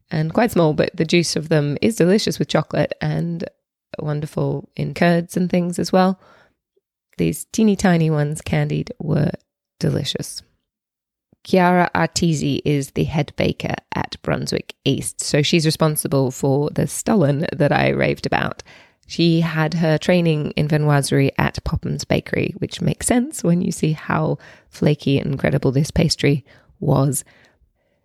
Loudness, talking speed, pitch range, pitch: -19 LUFS, 145 wpm, 145-175 Hz, 155 Hz